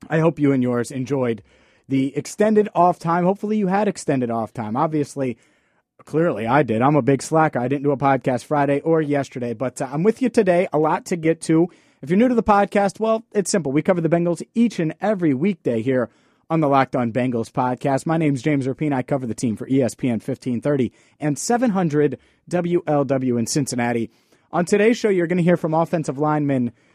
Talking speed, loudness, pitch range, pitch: 210 wpm, -20 LUFS, 130-175 Hz, 150 Hz